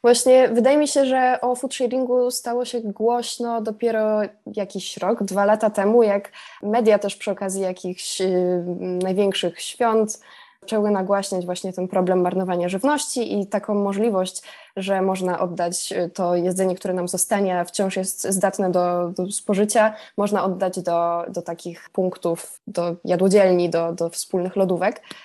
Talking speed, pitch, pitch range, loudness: 145 wpm, 195 Hz, 180-220 Hz, -21 LUFS